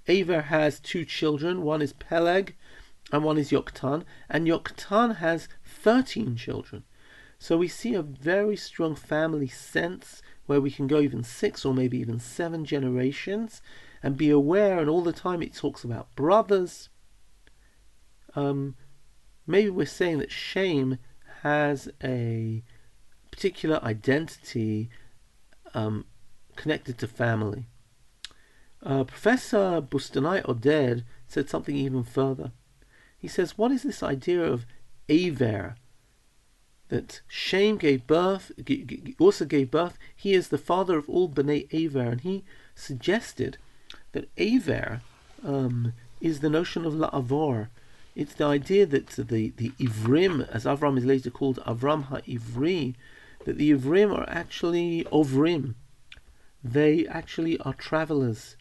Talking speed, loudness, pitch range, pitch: 130 wpm, -27 LUFS, 125-165 Hz, 140 Hz